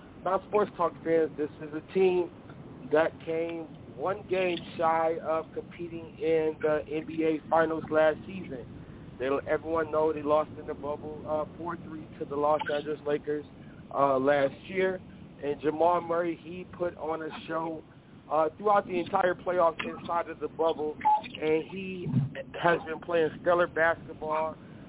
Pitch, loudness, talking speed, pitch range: 160 Hz, -29 LUFS, 150 wpm, 150-170 Hz